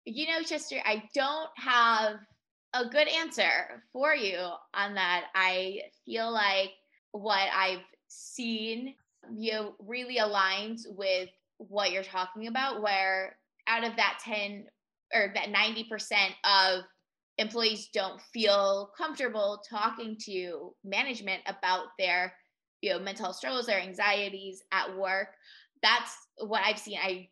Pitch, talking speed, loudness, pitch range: 205 Hz, 130 wpm, -29 LUFS, 190-225 Hz